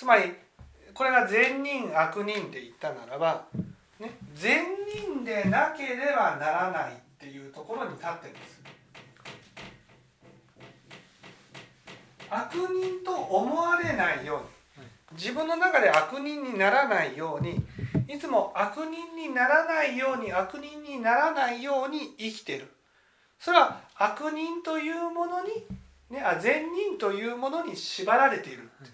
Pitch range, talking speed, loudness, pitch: 210-330 Hz, 260 characters per minute, -27 LUFS, 275 Hz